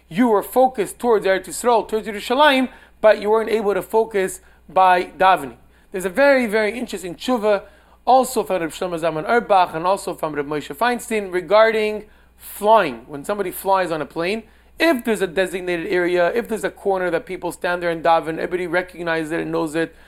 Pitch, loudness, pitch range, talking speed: 190 Hz, -19 LUFS, 175-220 Hz, 190 wpm